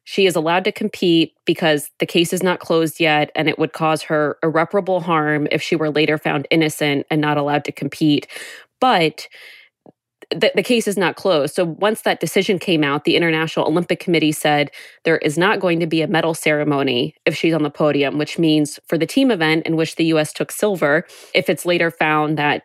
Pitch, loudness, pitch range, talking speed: 160 Hz, -18 LUFS, 150-175 Hz, 210 wpm